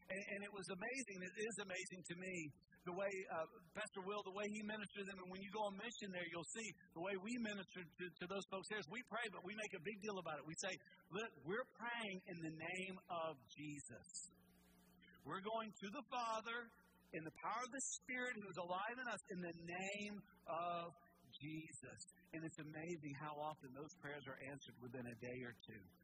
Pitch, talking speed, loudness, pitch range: 185 Hz, 220 wpm, -50 LUFS, 160-205 Hz